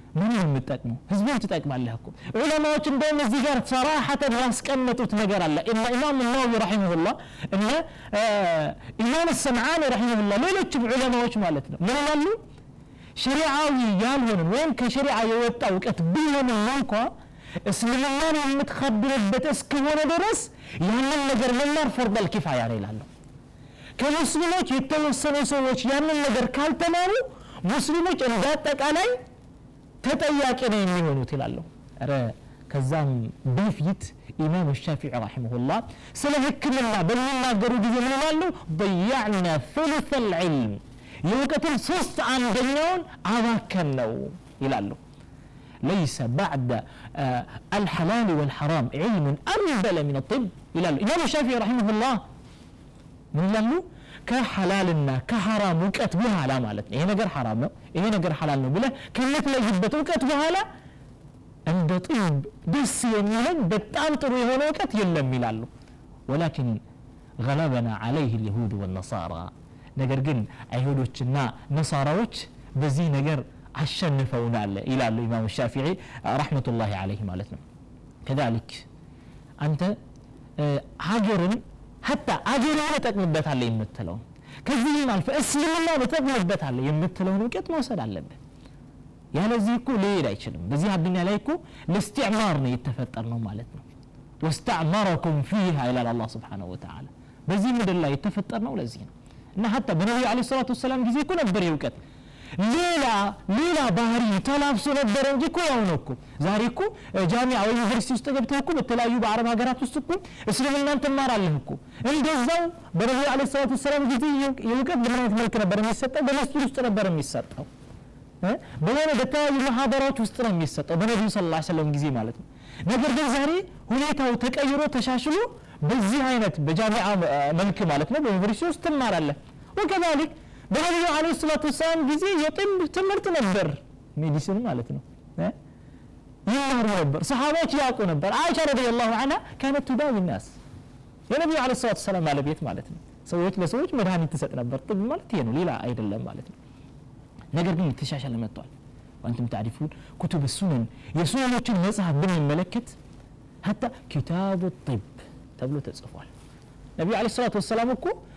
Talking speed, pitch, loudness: 120 wpm, 210 Hz, -25 LUFS